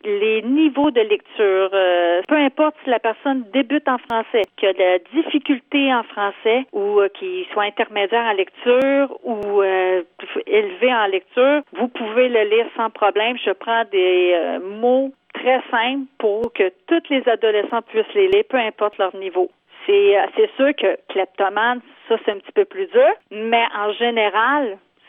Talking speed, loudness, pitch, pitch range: 175 wpm, -18 LUFS, 235 Hz, 205-290 Hz